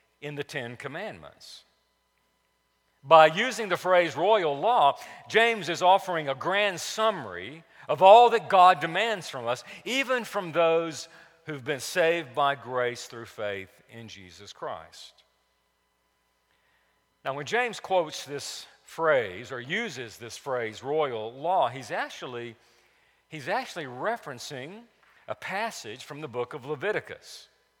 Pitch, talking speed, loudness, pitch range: 155 Hz, 130 wpm, -25 LUFS, 125-185 Hz